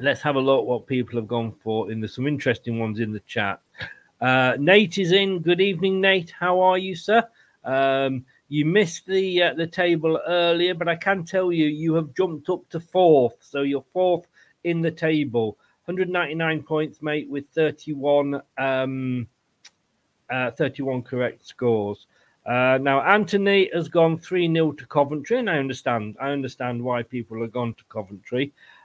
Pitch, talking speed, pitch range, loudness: 150 Hz, 175 wpm, 125-175 Hz, -23 LUFS